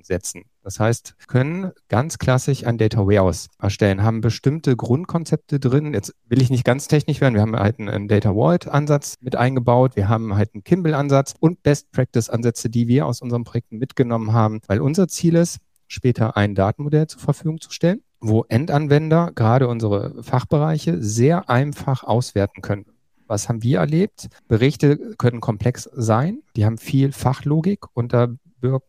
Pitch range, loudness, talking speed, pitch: 110-145 Hz, -20 LUFS, 165 wpm, 125 Hz